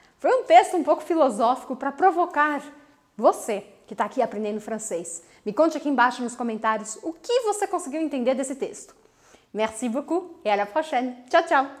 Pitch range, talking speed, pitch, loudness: 240-330 Hz, 180 wpm, 275 Hz, -24 LUFS